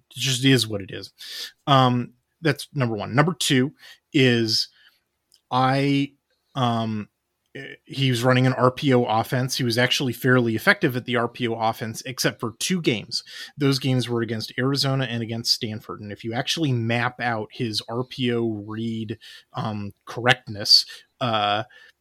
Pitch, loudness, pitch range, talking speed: 125 Hz, -22 LUFS, 115-135 Hz, 145 wpm